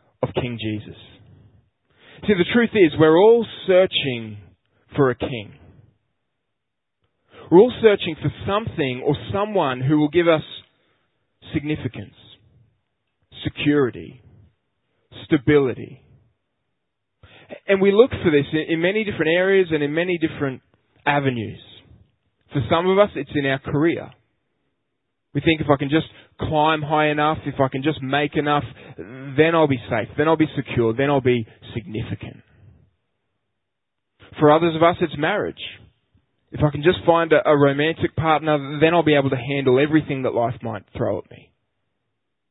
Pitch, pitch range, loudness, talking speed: 140 Hz, 115-155 Hz, -20 LUFS, 145 wpm